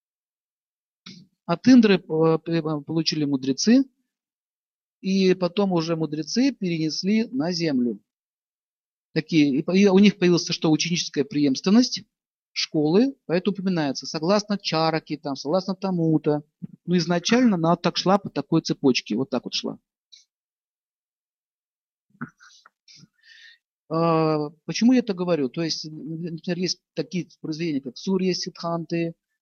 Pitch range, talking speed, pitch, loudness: 160-195 Hz, 105 wpm, 170 Hz, -23 LUFS